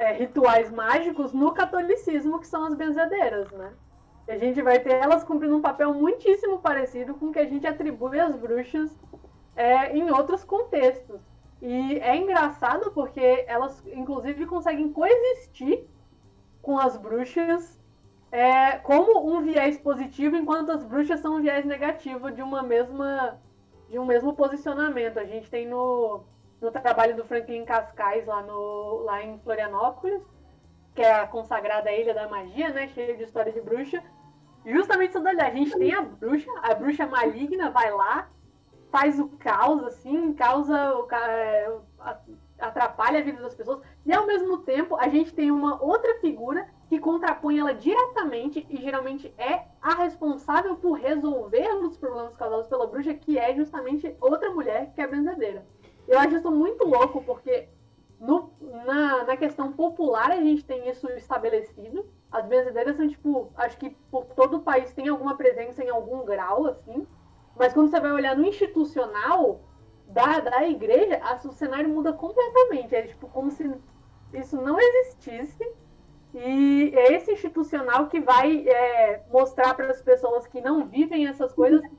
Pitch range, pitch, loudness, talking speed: 250-320 Hz, 280 Hz, -24 LUFS, 160 wpm